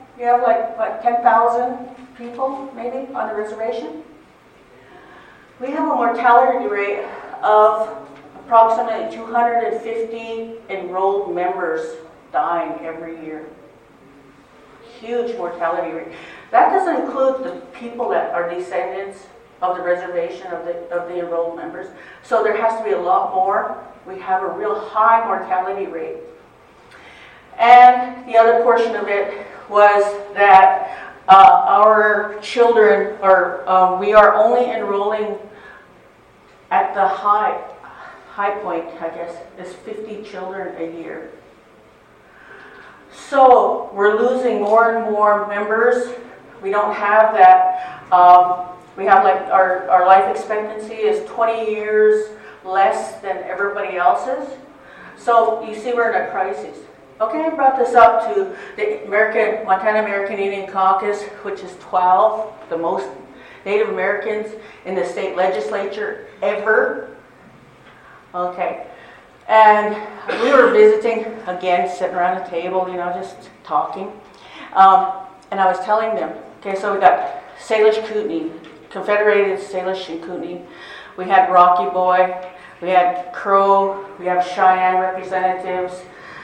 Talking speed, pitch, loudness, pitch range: 130 wpm, 205 Hz, -16 LUFS, 185-230 Hz